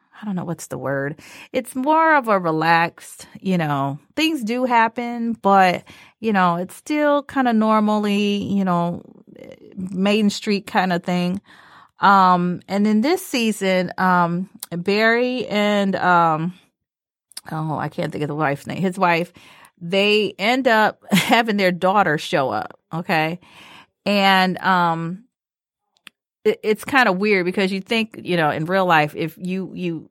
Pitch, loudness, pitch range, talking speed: 190 Hz, -19 LUFS, 175-220 Hz, 155 wpm